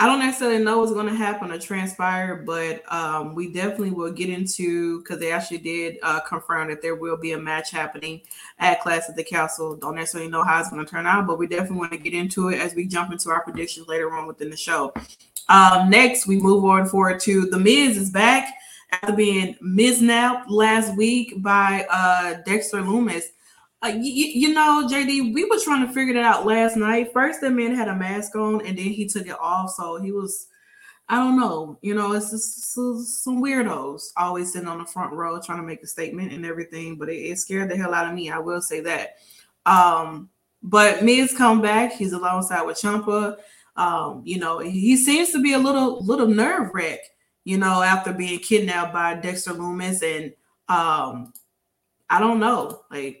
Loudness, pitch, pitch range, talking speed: -21 LUFS, 190 Hz, 170-225 Hz, 210 wpm